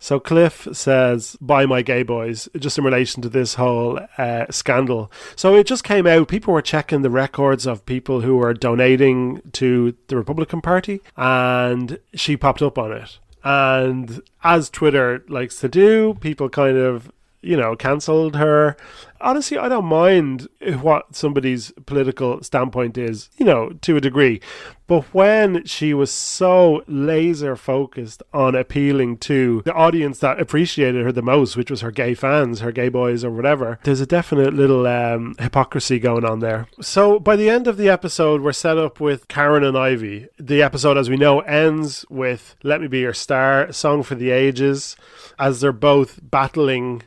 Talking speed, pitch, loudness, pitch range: 175 wpm, 135 Hz, -18 LUFS, 125-155 Hz